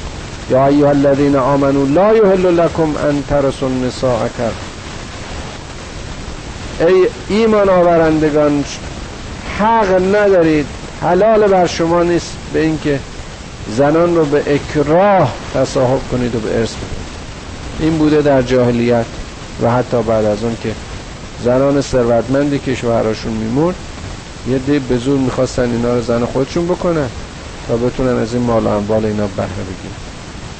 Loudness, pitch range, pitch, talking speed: -14 LUFS, 115-155 Hz, 130 Hz, 125 wpm